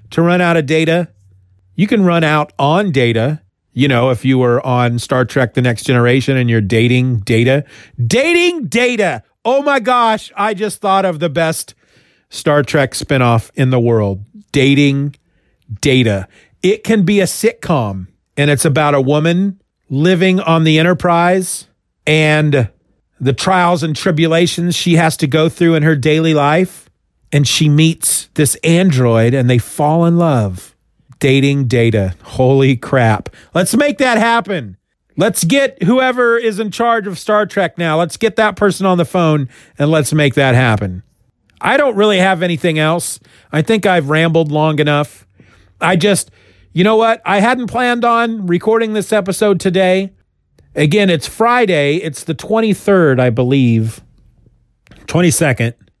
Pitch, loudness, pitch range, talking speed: 155 Hz, -13 LUFS, 130-190 Hz, 160 wpm